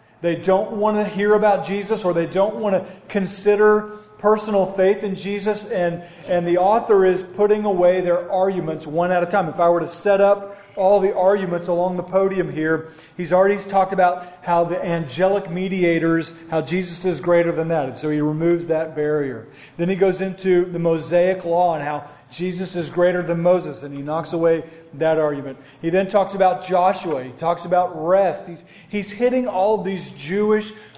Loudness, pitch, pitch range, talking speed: -20 LUFS, 180 Hz, 165-195 Hz, 190 wpm